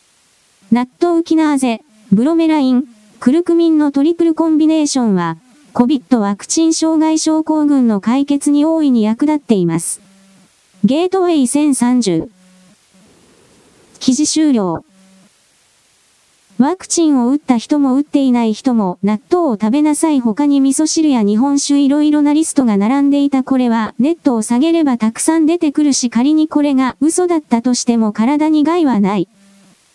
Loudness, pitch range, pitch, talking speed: -13 LUFS, 220-305 Hz, 270 Hz, 315 characters per minute